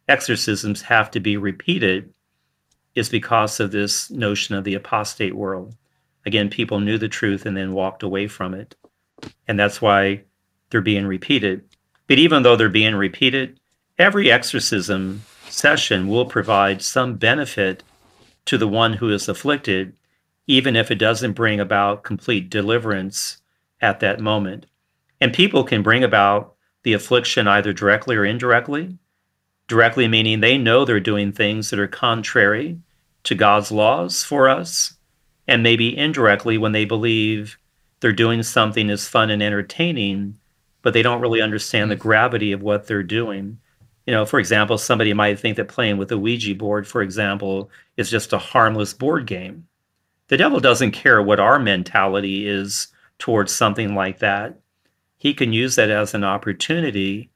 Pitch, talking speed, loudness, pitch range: 105 Hz, 160 wpm, -18 LUFS, 100-115 Hz